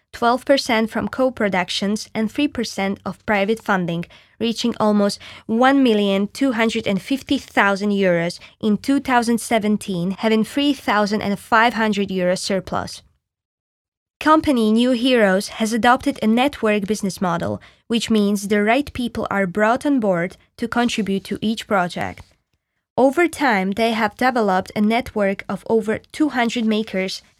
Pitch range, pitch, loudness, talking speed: 200-240 Hz, 220 Hz, -19 LUFS, 110 wpm